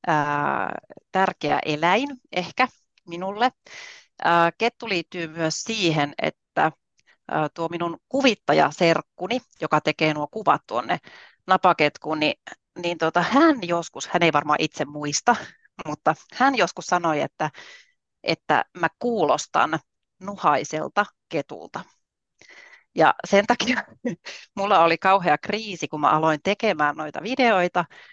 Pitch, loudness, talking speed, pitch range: 175 Hz, -23 LUFS, 110 wpm, 155-225 Hz